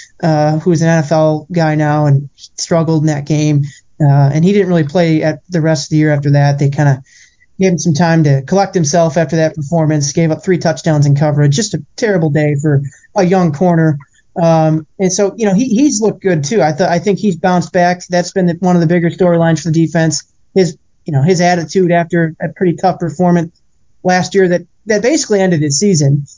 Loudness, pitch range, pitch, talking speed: -12 LUFS, 155-180 Hz, 165 Hz, 225 wpm